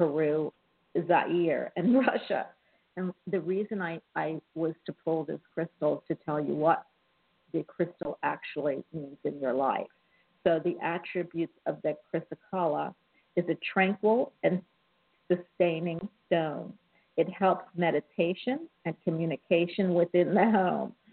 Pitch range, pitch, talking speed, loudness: 165-190 Hz, 175 Hz, 130 wpm, -30 LUFS